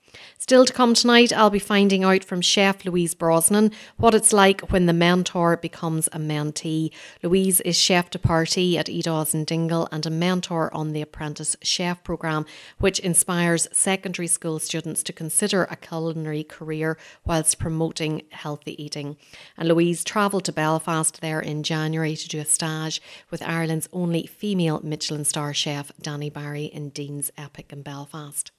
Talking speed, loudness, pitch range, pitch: 165 wpm, -22 LUFS, 155-180 Hz, 165 Hz